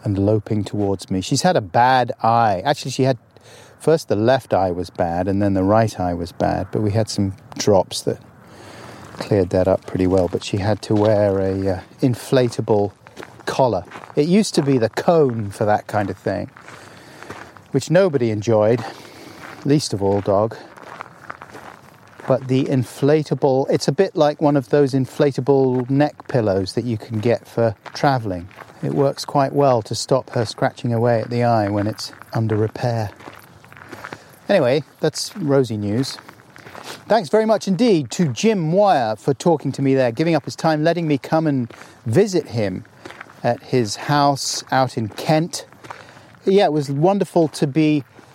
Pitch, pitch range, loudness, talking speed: 125 Hz, 110-145 Hz, -19 LUFS, 170 wpm